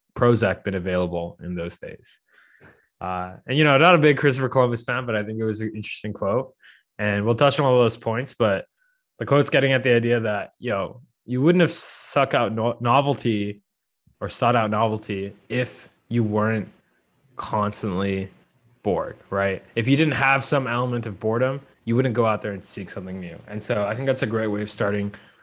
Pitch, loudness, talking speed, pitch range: 115 Hz, -22 LUFS, 200 wpm, 105-130 Hz